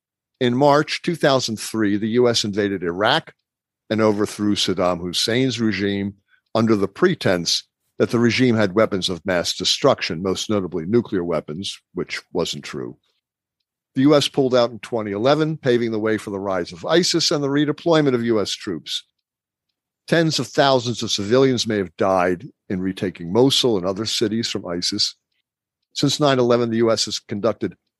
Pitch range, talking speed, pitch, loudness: 100-130 Hz, 155 wpm, 115 Hz, -20 LUFS